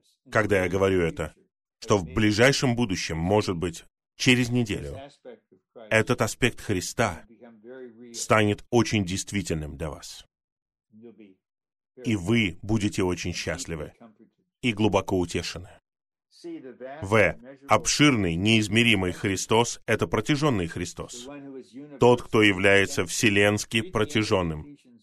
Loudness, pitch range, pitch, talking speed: -24 LUFS, 95-120 Hz, 110 Hz, 95 wpm